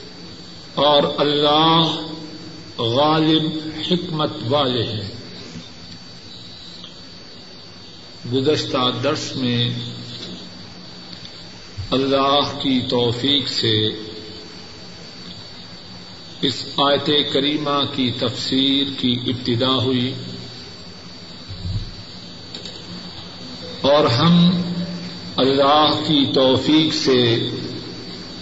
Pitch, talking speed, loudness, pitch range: 130 Hz, 55 wpm, -18 LUFS, 90-150 Hz